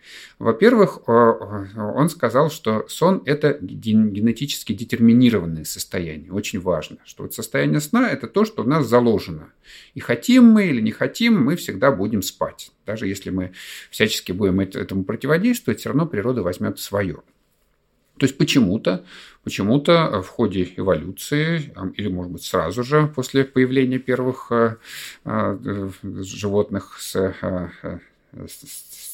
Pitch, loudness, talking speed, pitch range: 115 Hz, -20 LUFS, 130 wpm, 95-145 Hz